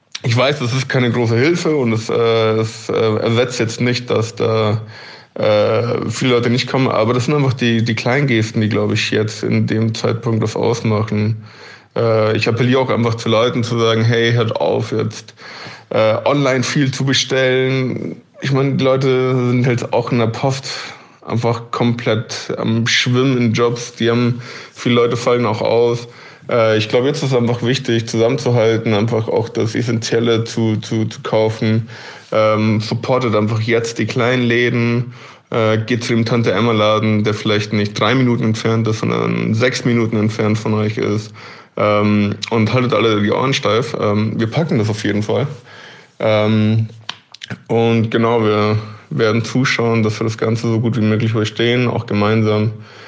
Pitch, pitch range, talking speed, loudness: 115 Hz, 110-120 Hz, 175 wpm, -16 LUFS